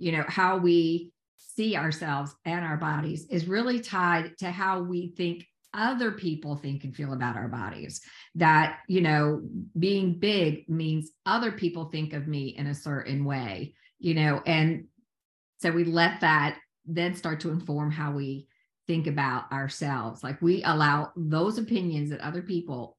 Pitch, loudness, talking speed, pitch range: 160 Hz, -28 LUFS, 165 wpm, 145-175 Hz